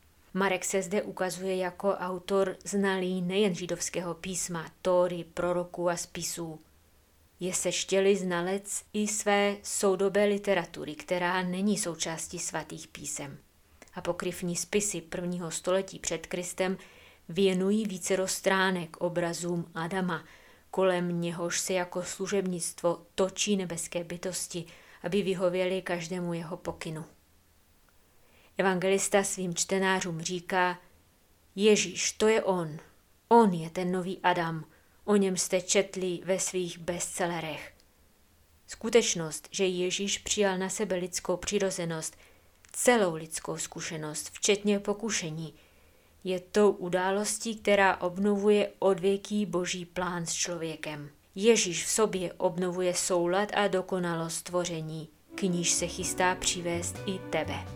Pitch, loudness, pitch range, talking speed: 180 Hz, -29 LUFS, 170-195 Hz, 110 wpm